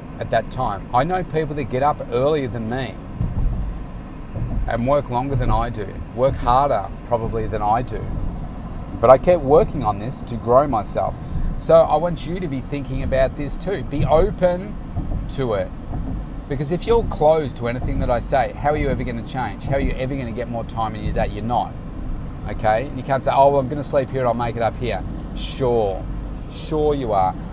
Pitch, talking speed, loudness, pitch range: 130 Hz, 215 wpm, -21 LUFS, 115-145 Hz